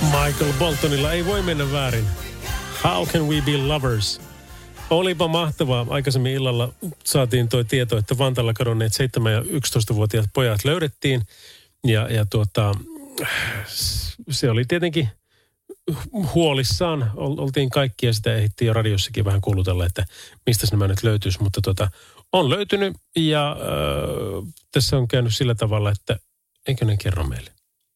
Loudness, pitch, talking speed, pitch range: -22 LUFS, 120 Hz, 135 wpm, 105-145 Hz